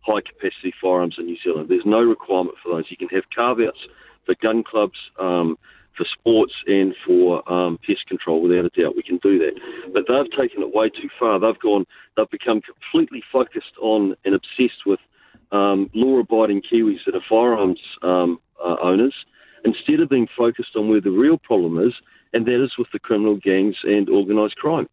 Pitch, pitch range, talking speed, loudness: 105 Hz, 90-125 Hz, 195 wpm, -20 LUFS